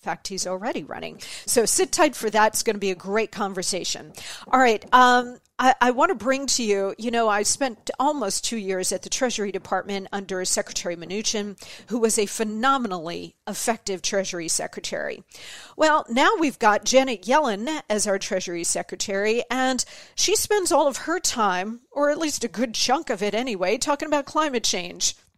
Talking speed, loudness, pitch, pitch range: 170 wpm, -23 LUFS, 225 Hz, 200-270 Hz